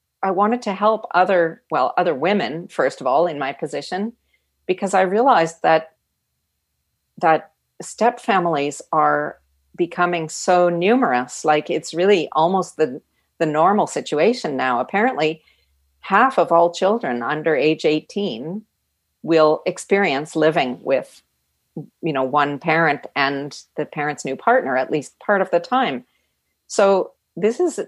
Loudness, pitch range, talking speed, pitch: -19 LUFS, 145-195 Hz, 140 wpm, 165 Hz